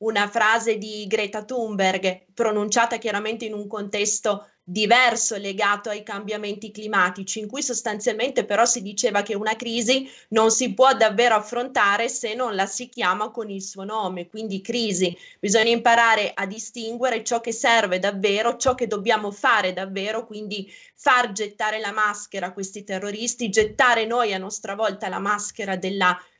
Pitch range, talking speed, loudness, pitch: 205-235 Hz, 155 wpm, -22 LUFS, 215 Hz